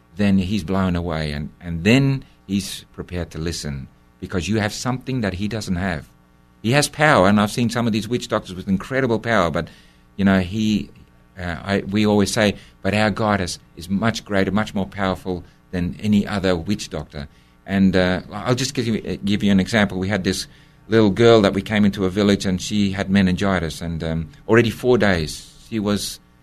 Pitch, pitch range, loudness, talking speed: 100 Hz, 90-105 Hz, -20 LUFS, 200 wpm